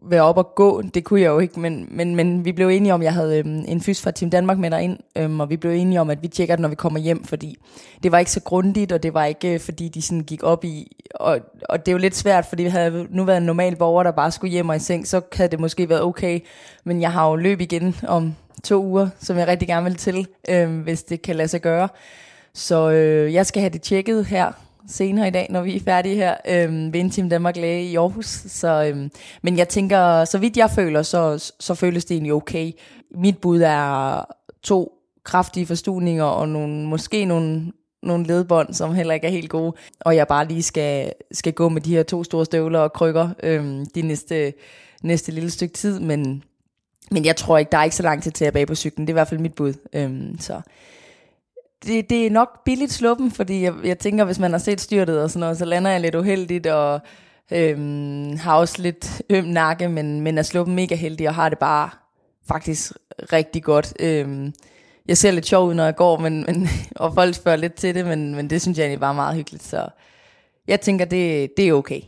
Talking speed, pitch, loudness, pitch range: 235 wpm, 170 Hz, -20 LUFS, 160-180 Hz